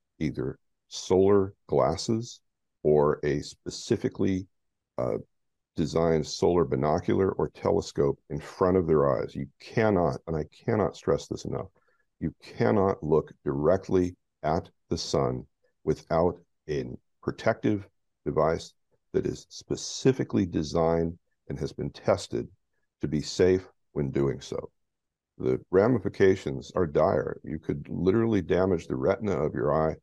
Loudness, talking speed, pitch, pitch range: -28 LUFS, 125 wpm, 85 Hz, 75-95 Hz